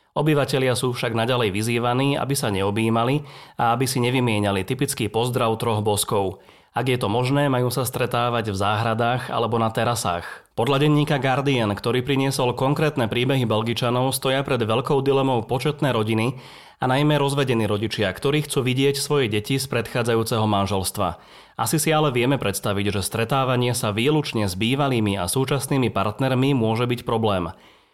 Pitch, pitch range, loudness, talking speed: 125 Hz, 110-135 Hz, -22 LUFS, 155 wpm